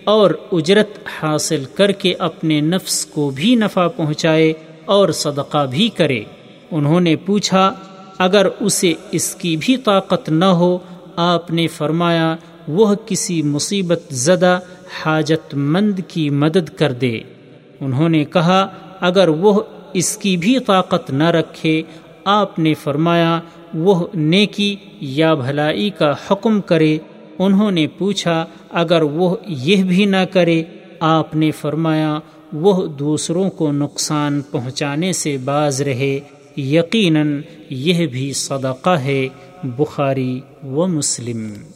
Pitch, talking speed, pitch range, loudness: 165 Hz, 125 wpm, 150-190 Hz, -17 LUFS